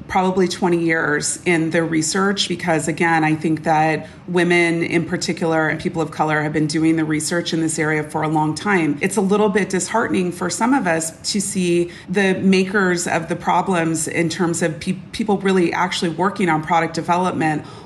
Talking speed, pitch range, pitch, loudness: 190 wpm, 160-185 Hz, 170 Hz, -19 LUFS